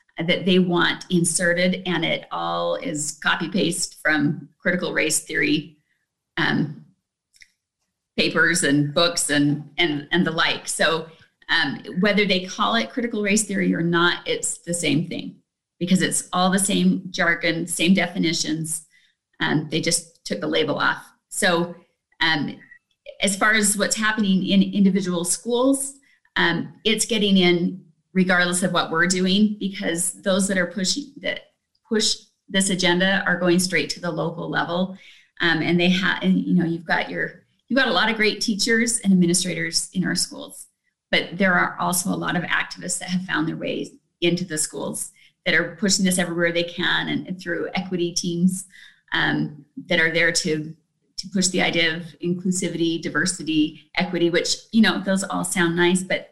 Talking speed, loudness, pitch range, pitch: 170 wpm, -21 LUFS, 165-195 Hz, 180 Hz